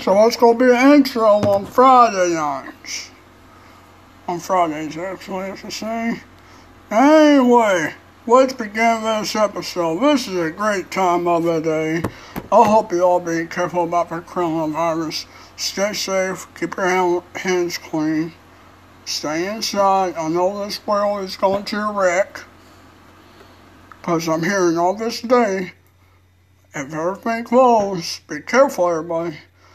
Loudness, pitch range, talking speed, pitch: -18 LUFS, 165-215 Hz, 130 wpm, 180 Hz